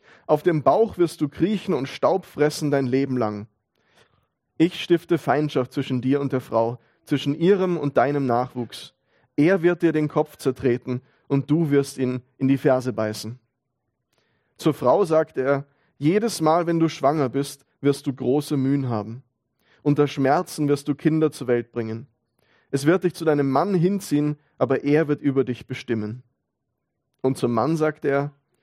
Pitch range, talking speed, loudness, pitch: 125-155 Hz, 170 wpm, -23 LUFS, 140 Hz